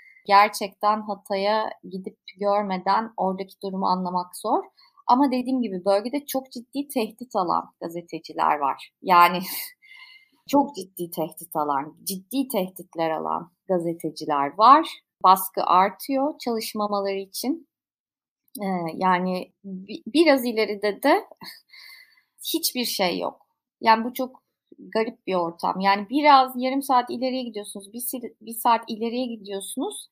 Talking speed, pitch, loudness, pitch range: 110 wpm, 210 Hz, -23 LUFS, 185-260 Hz